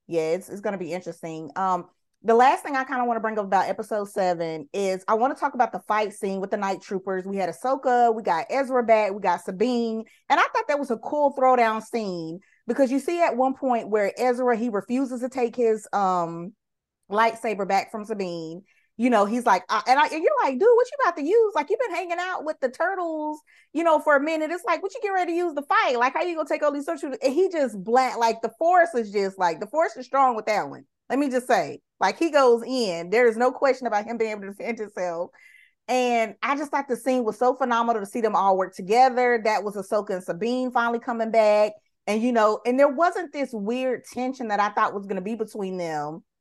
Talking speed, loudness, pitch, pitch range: 250 wpm, -24 LUFS, 235 Hz, 205-275 Hz